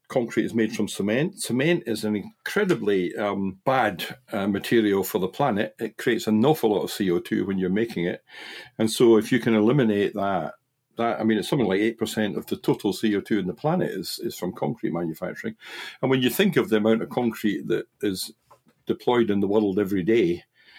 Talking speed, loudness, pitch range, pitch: 210 wpm, -24 LUFS, 100-115 Hz, 110 Hz